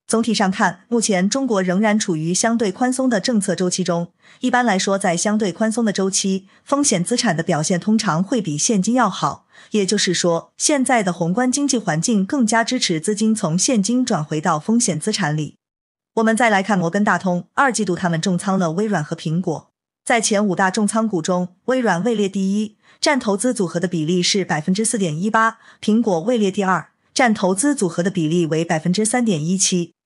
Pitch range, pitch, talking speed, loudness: 180-230 Hz, 200 Hz, 305 characters per minute, -19 LUFS